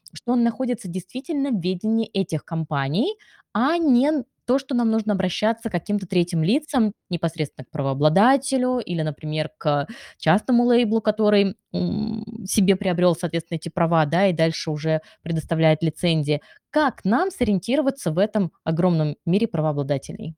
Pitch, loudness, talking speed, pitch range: 195 Hz, -22 LUFS, 140 wpm, 160-230 Hz